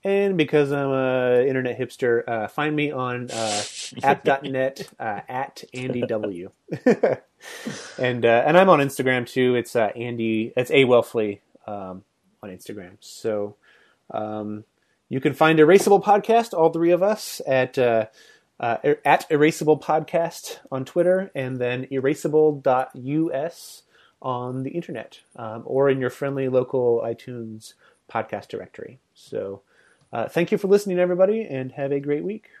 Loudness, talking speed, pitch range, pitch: -22 LUFS, 145 wpm, 125-160 Hz, 135 Hz